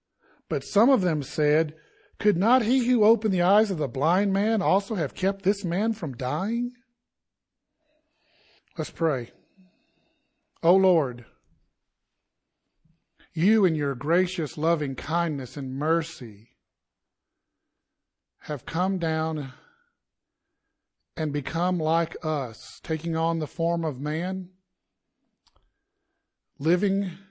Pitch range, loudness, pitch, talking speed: 155-210 Hz, -25 LUFS, 175 Hz, 110 wpm